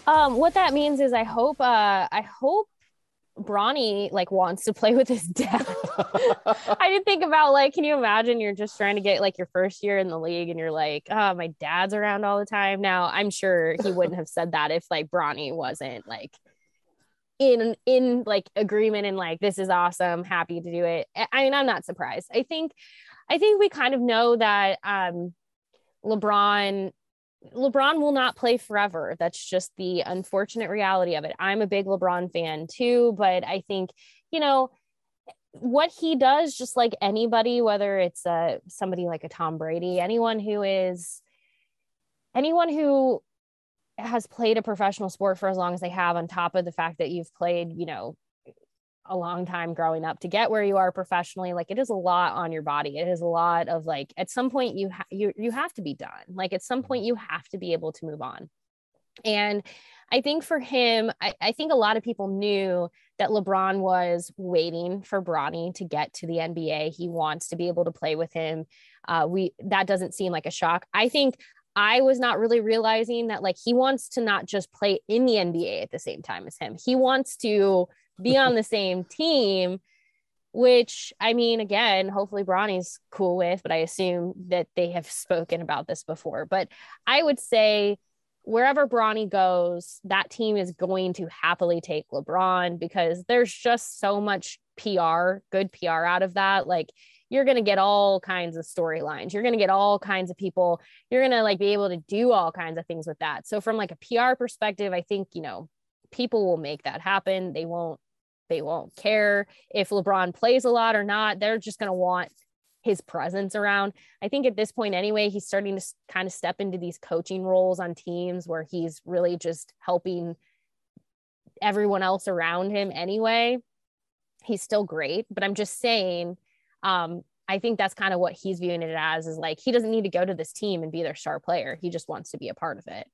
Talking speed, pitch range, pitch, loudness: 205 wpm, 175-225 Hz, 195 Hz, -25 LUFS